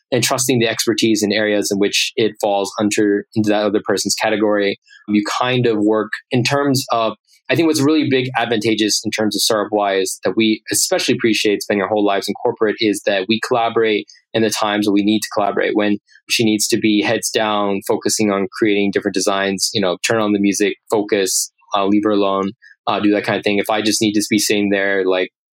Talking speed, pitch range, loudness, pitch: 220 wpm, 100-110 Hz, -17 LUFS, 105 Hz